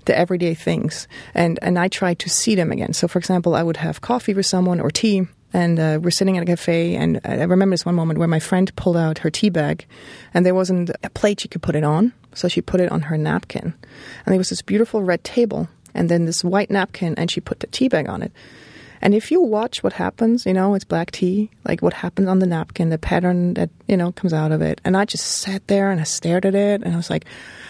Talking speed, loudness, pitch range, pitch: 260 wpm, -19 LUFS, 170-195 Hz, 180 Hz